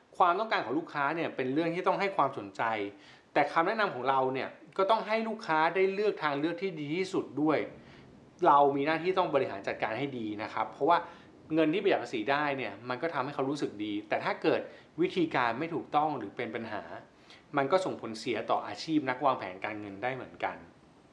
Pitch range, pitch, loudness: 130-190 Hz, 155 Hz, -31 LUFS